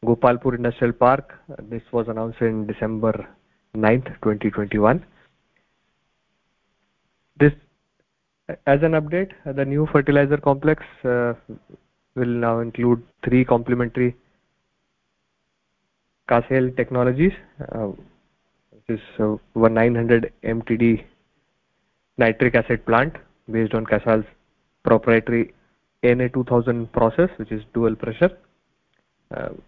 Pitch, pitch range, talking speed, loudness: 120 Hz, 115-130 Hz, 100 wpm, -21 LUFS